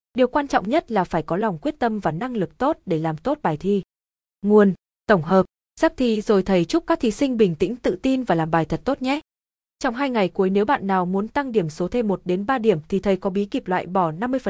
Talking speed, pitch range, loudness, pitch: 265 wpm, 185-260 Hz, -22 LUFS, 205 Hz